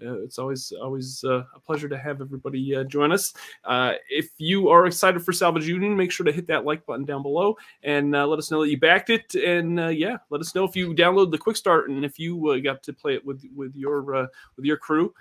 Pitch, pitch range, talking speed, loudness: 150 Hz, 140-175 Hz, 260 wpm, -23 LUFS